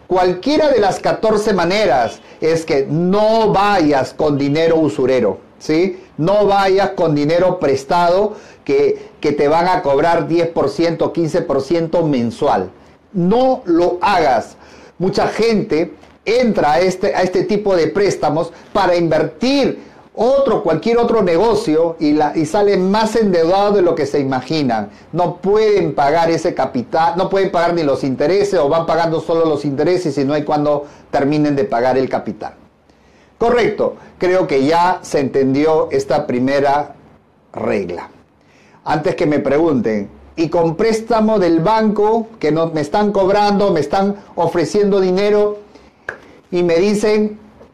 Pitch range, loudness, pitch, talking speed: 150-205 Hz, -15 LUFS, 175 Hz, 140 wpm